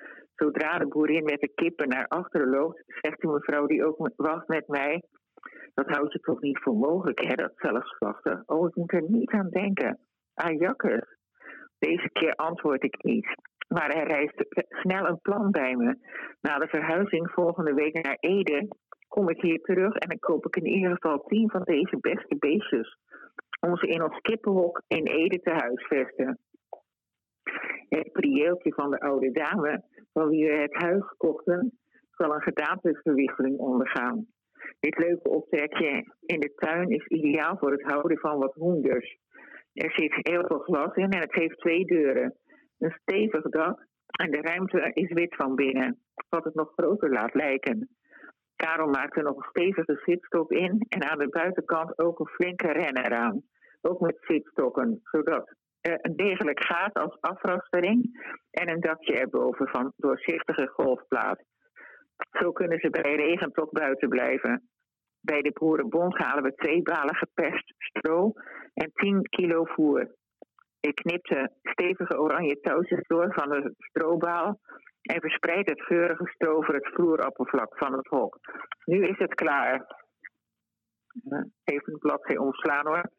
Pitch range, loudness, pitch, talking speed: 155-195 Hz, -27 LUFS, 170 Hz, 160 wpm